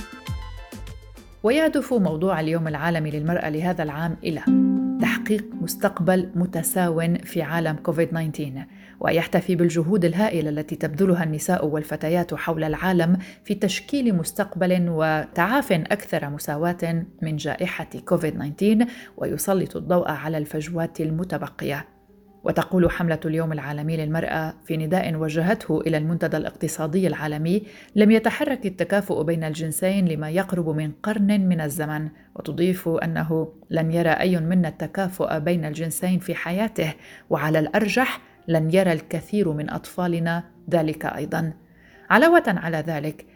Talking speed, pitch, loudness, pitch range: 120 wpm, 165 Hz, -23 LUFS, 155-185 Hz